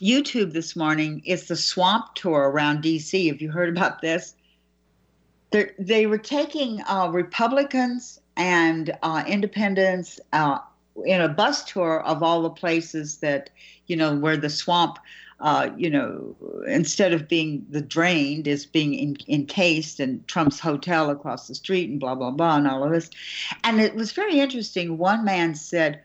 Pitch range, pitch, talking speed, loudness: 155-195 Hz, 165 Hz, 165 wpm, -23 LUFS